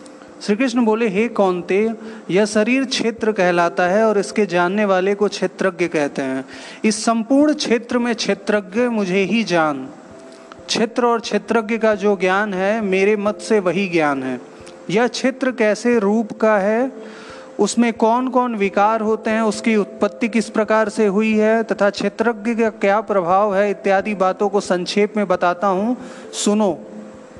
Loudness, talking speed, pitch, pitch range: -18 LUFS, 160 wpm, 210 Hz, 195-230 Hz